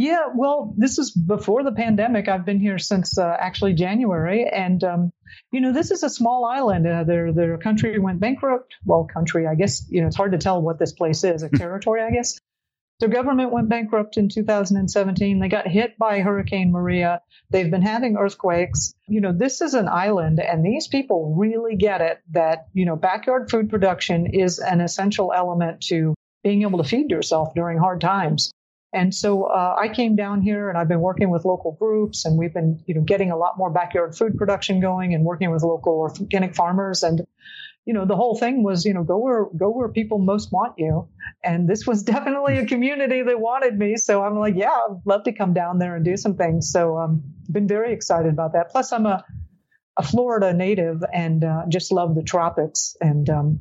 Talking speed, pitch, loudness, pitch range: 210 wpm, 195 Hz, -21 LUFS, 170-220 Hz